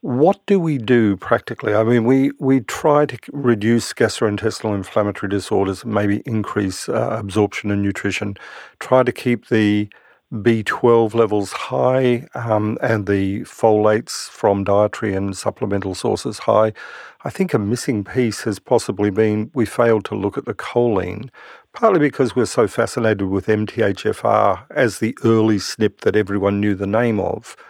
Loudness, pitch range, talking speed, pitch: -18 LUFS, 100-120 Hz, 150 wpm, 110 Hz